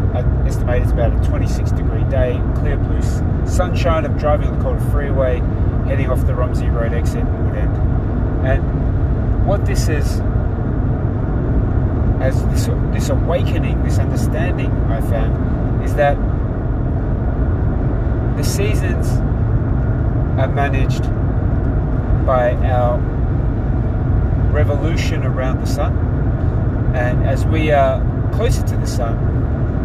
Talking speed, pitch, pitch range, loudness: 115 wpm, 115 Hz, 105-120 Hz, -18 LUFS